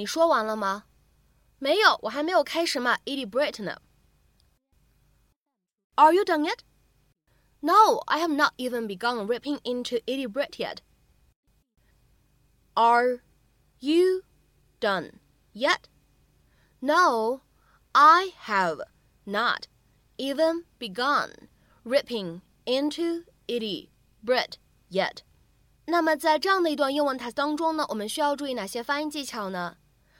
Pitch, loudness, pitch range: 280 Hz, -25 LUFS, 240-320 Hz